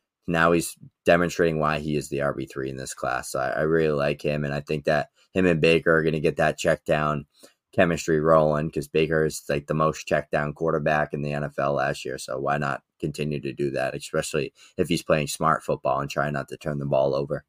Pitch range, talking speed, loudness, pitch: 70-80 Hz, 235 wpm, -25 LUFS, 75 Hz